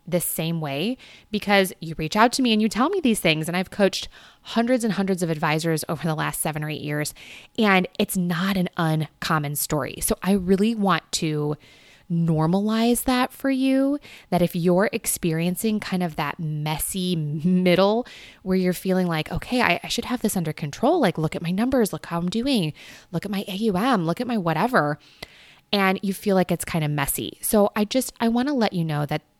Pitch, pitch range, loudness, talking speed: 185 Hz, 160-215 Hz, -23 LUFS, 205 wpm